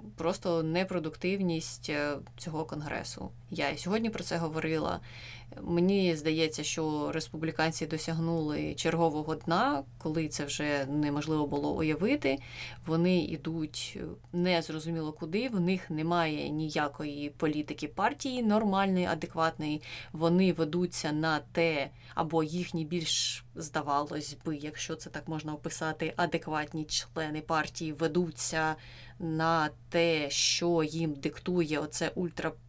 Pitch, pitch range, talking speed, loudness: 160 Hz, 150-170 Hz, 110 wpm, -32 LUFS